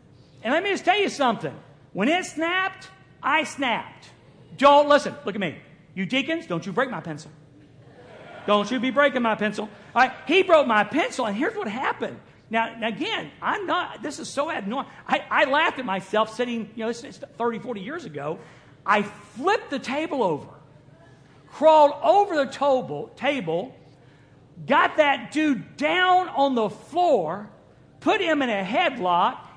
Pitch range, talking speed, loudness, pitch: 180-295 Hz, 170 wpm, -23 LUFS, 235 Hz